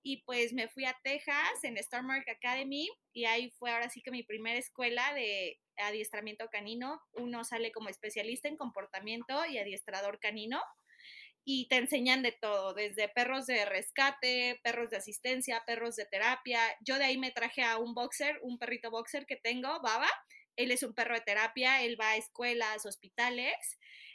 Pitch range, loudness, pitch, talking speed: 225-260 Hz, -34 LUFS, 240 Hz, 175 wpm